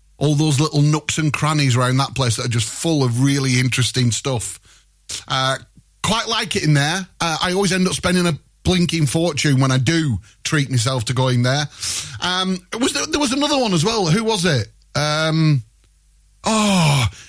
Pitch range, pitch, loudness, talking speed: 125-175 Hz, 145 Hz, -18 LUFS, 185 wpm